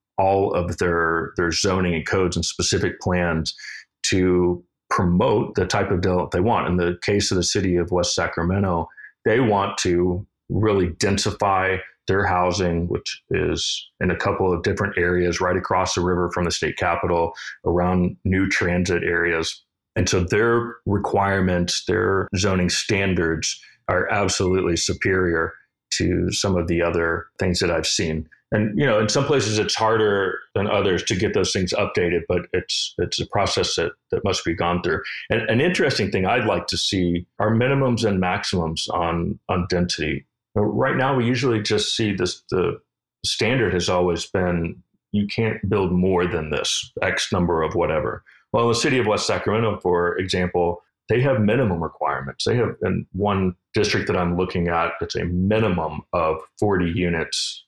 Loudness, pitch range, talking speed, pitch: -21 LUFS, 85-100 Hz, 170 wpm, 90 Hz